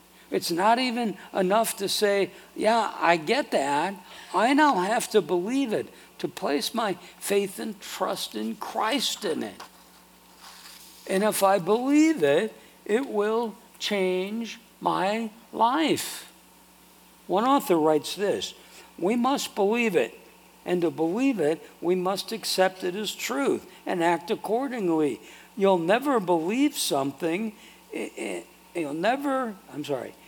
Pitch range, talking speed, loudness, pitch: 180-230 Hz, 135 wpm, -26 LUFS, 205 Hz